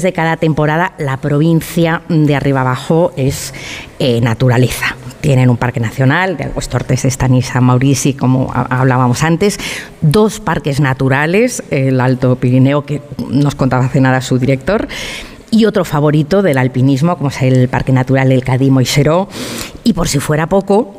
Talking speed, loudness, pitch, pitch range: 155 wpm, -13 LUFS, 140 Hz, 130-165 Hz